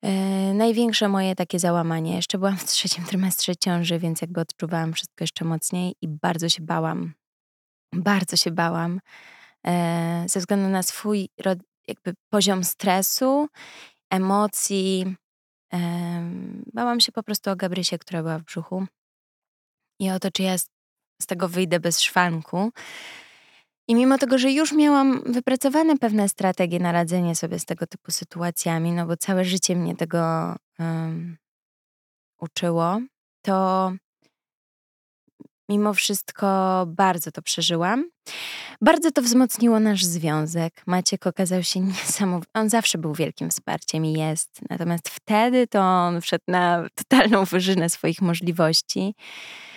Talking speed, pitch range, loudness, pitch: 135 wpm, 170-205 Hz, -23 LUFS, 185 Hz